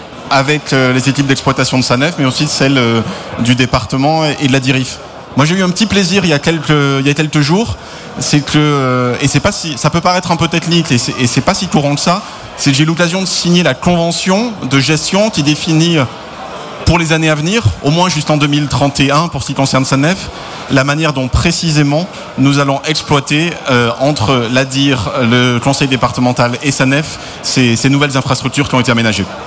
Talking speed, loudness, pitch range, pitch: 210 wpm, -12 LUFS, 130-160 Hz, 145 Hz